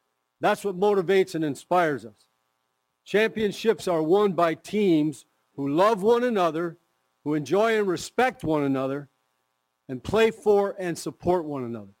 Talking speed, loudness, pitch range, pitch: 140 wpm, -24 LUFS, 125-200 Hz, 165 Hz